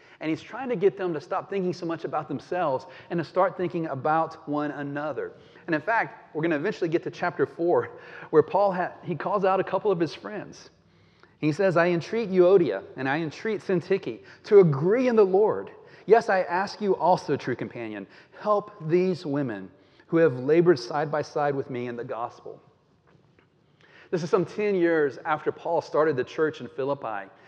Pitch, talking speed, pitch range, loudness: 170 Hz, 195 wpm, 150-195 Hz, -25 LUFS